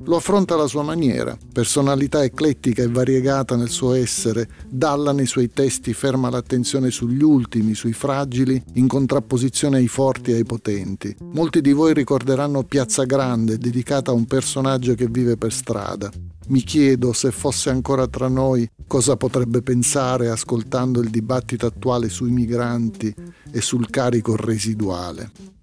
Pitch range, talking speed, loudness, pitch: 115-135 Hz, 150 wpm, -20 LUFS, 125 Hz